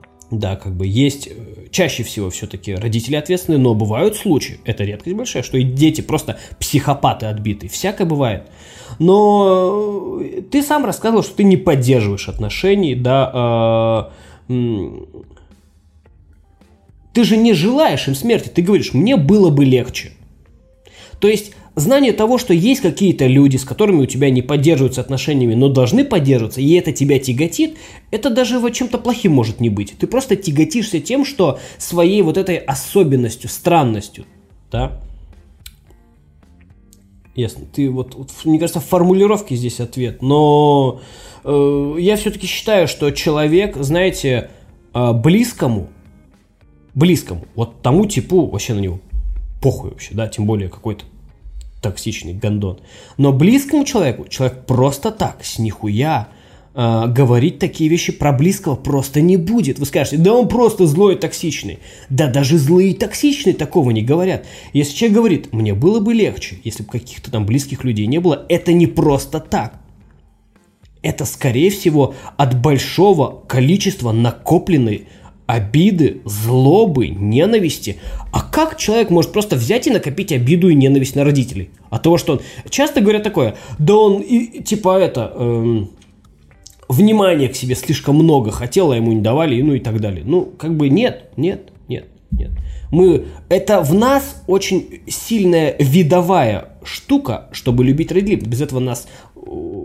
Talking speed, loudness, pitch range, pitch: 145 wpm, -15 LUFS, 110-185 Hz, 140 Hz